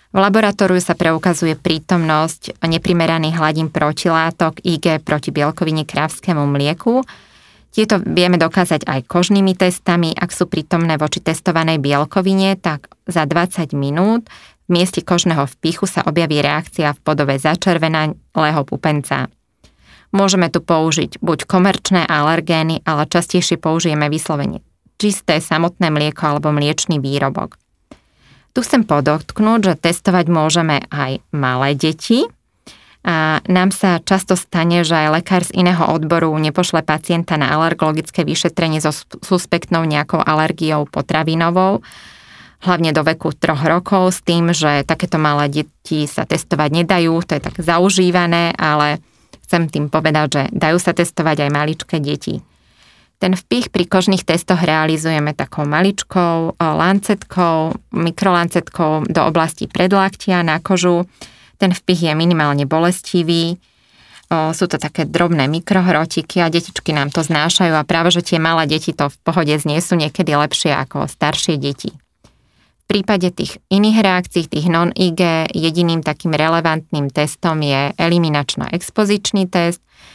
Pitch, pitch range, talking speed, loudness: 165 Hz, 155-180 Hz, 135 wpm, -16 LUFS